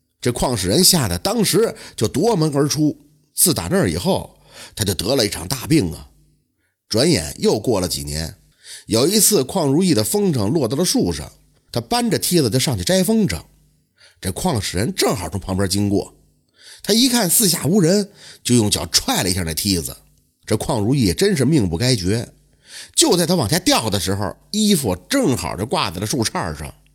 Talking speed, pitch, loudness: 265 characters per minute, 135 Hz, -18 LUFS